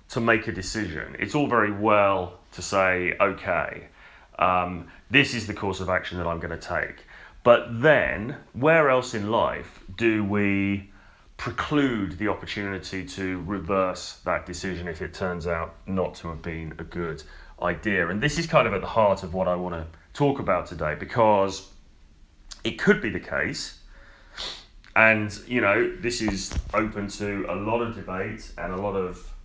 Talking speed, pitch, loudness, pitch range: 175 wpm, 95 Hz, -25 LUFS, 90-110 Hz